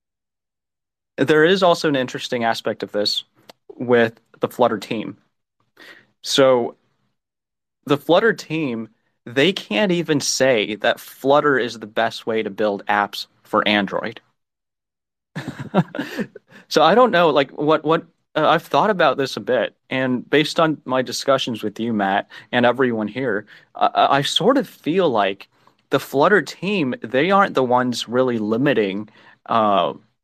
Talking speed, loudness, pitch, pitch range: 145 wpm, -19 LUFS, 125 Hz, 110-145 Hz